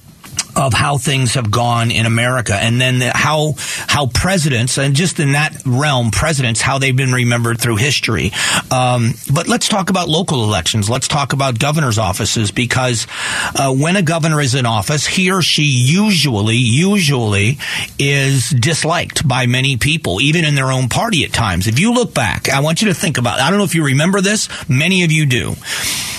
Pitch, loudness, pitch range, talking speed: 135 Hz, -14 LUFS, 120-160 Hz, 190 wpm